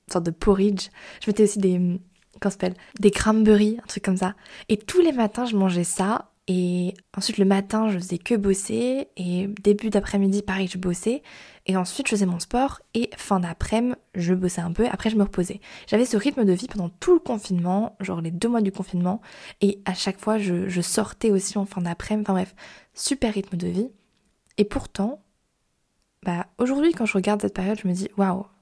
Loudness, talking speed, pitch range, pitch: -24 LUFS, 205 wpm, 185-220 Hz, 200 Hz